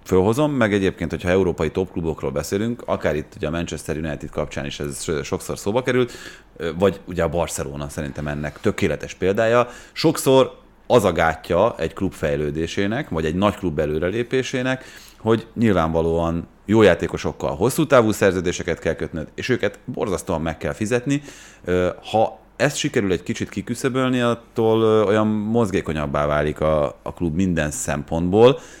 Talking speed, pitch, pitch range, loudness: 140 wpm, 95 Hz, 80-115 Hz, -21 LUFS